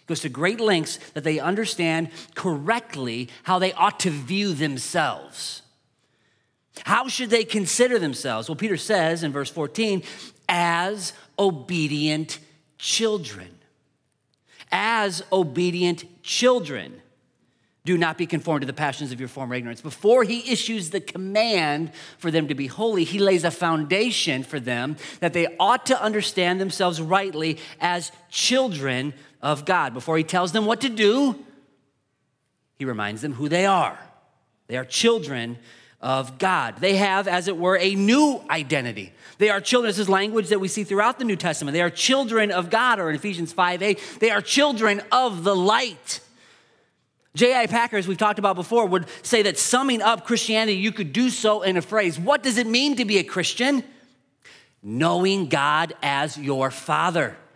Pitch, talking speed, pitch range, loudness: 180 Hz, 165 wpm, 155-215 Hz, -22 LUFS